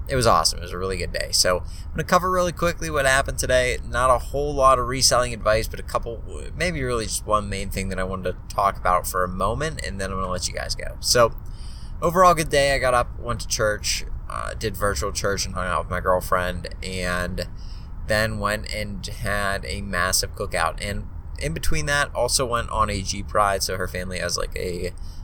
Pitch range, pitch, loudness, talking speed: 90-120 Hz, 100 Hz, -23 LUFS, 230 wpm